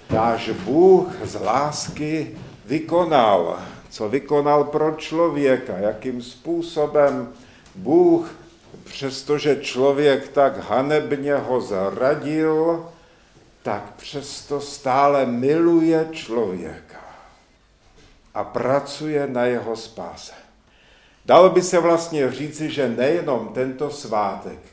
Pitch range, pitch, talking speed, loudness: 130-160 Hz, 145 Hz, 90 wpm, -20 LUFS